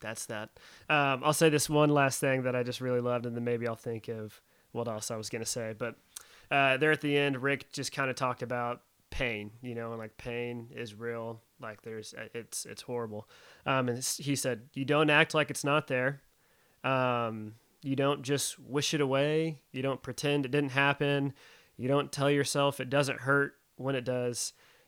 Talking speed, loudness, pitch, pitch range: 205 wpm, -31 LUFS, 130 Hz, 120-140 Hz